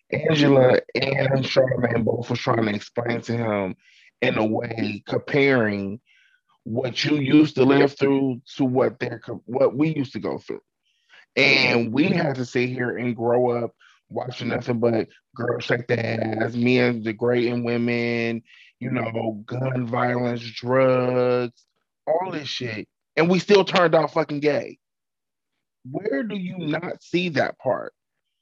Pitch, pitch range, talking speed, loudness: 125 Hz, 120-140 Hz, 150 wpm, -22 LUFS